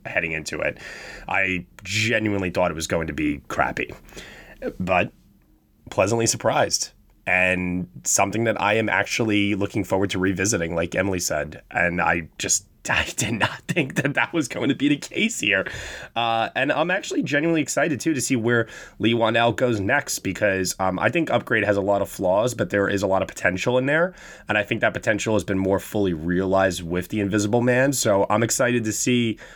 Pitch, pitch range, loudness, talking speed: 105 Hz, 95-120 Hz, -22 LUFS, 195 wpm